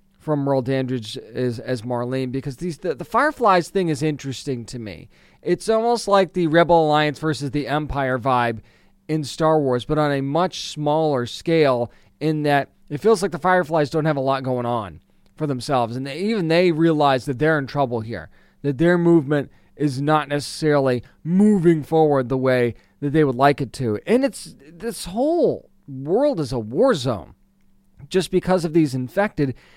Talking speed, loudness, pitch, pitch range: 180 wpm, -21 LUFS, 145 Hz, 130-170 Hz